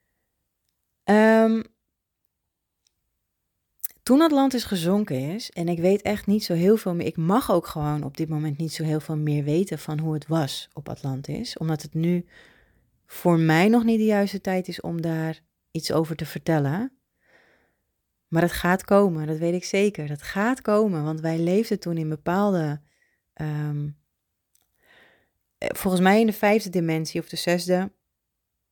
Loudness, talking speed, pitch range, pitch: -24 LUFS, 160 wpm, 150-200 Hz, 165 Hz